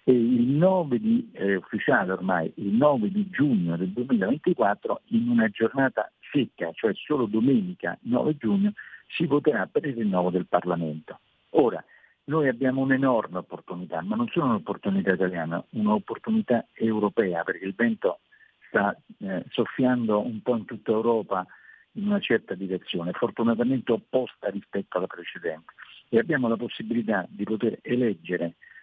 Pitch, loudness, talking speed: 120 Hz, -26 LUFS, 140 wpm